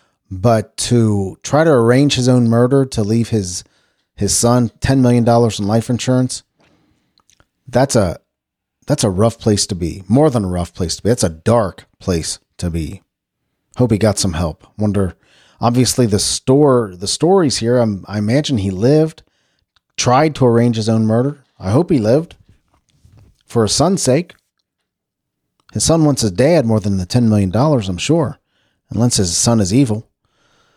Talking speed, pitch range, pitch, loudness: 175 wpm, 100-125 Hz, 115 Hz, -15 LUFS